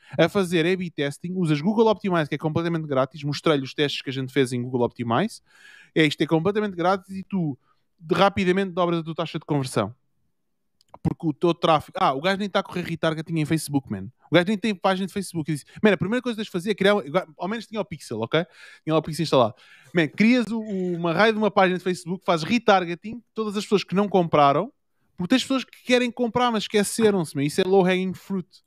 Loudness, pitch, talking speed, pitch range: -23 LUFS, 180 Hz, 230 wpm, 155-200 Hz